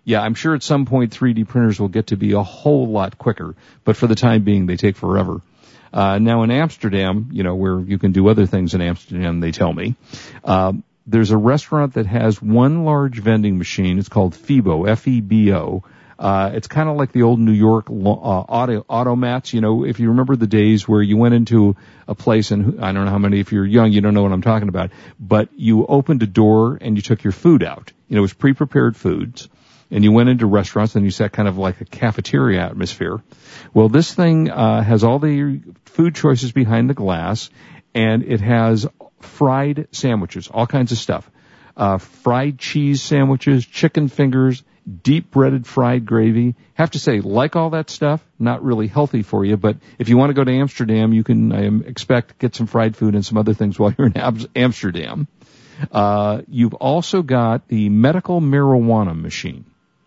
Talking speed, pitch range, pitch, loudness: 200 wpm, 105-130 Hz, 115 Hz, -17 LUFS